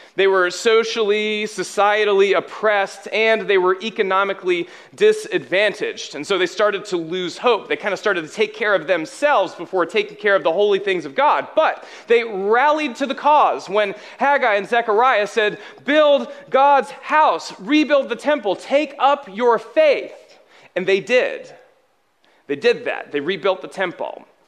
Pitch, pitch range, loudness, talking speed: 230 Hz, 200-300 Hz, -18 LUFS, 160 wpm